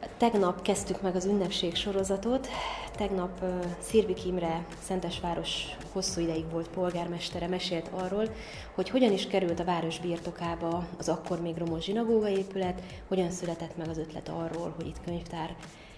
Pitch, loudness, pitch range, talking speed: 180 Hz, -31 LUFS, 170-190 Hz, 145 wpm